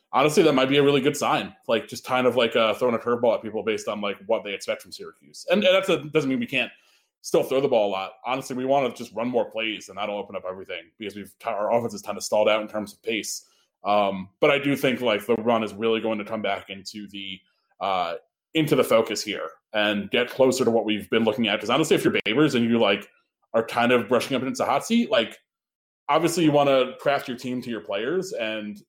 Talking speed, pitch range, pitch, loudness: 260 wpm, 105-140 Hz, 120 Hz, -24 LUFS